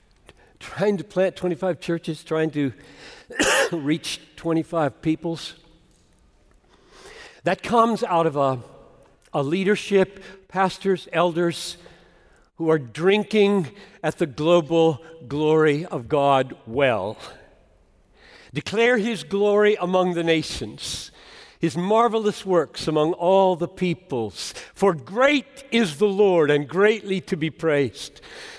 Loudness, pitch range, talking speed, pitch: -22 LUFS, 160-200 Hz, 110 wpm, 175 Hz